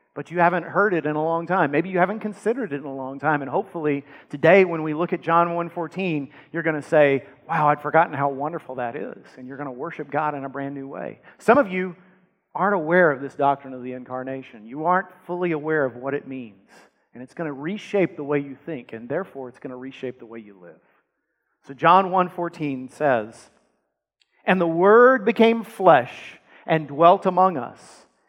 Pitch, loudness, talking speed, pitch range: 155 Hz, -22 LUFS, 210 wpm, 135-180 Hz